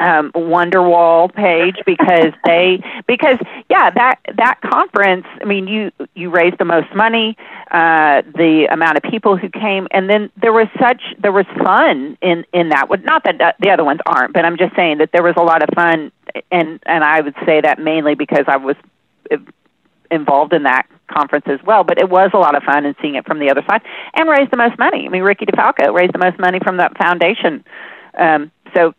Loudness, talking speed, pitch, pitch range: -13 LUFS, 210 wpm, 175 Hz, 160-205 Hz